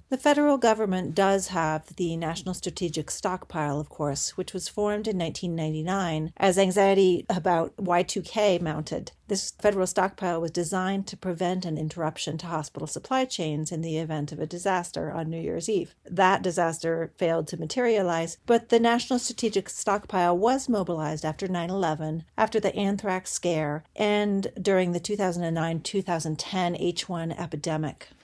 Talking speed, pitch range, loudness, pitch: 150 wpm, 165-195 Hz, -27 LUFS, 180 Hz